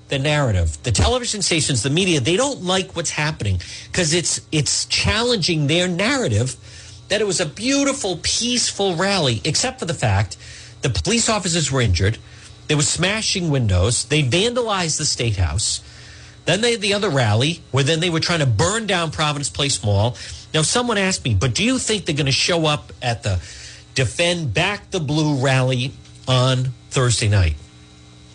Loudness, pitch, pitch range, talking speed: -19 LUFS, 150 Hz, 115-180 Hz, 175 wpm